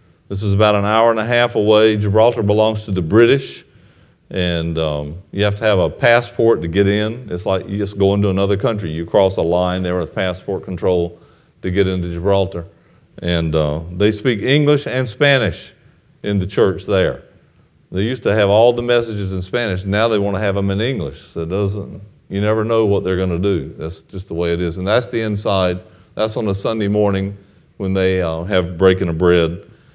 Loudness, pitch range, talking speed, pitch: -17 LUFS, 90-110 Hz, 210 wpm, 100 Hz